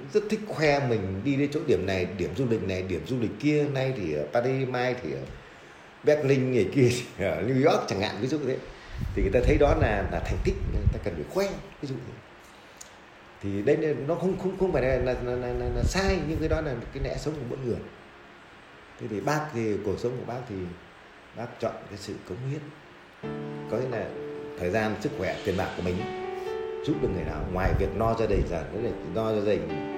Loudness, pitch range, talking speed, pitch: -28 LUFS, 95-145 Hz, 240 wpm, 125 Hz